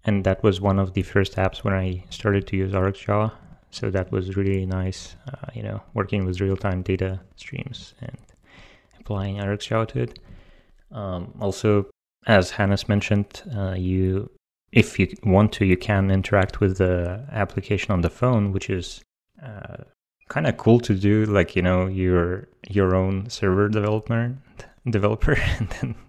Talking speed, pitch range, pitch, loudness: 165 wpm, 95-105 Hz, 100 Hz, -23 LUFS